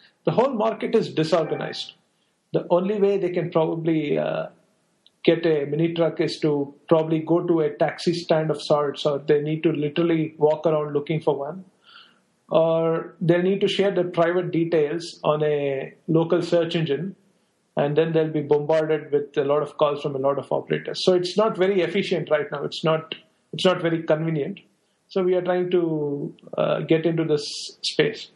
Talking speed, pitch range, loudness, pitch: 185 wpm, 150-180 Hz, -23 LUFS, 165 Hz